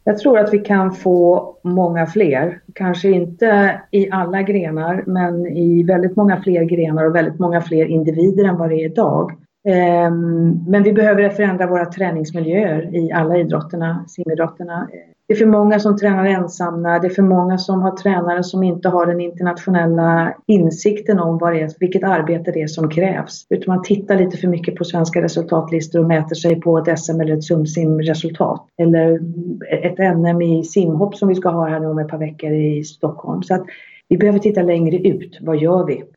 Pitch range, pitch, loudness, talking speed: 165-190 Hz, 175 Hz, -16 LUFS, 185 wpm